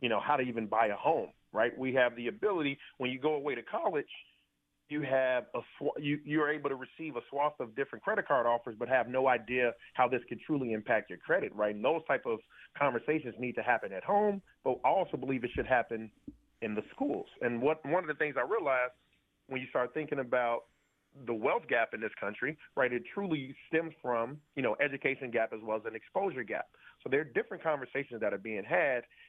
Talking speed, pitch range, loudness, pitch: 225 wpm, 120-150 Hz, -33 LUFS, 130 Hz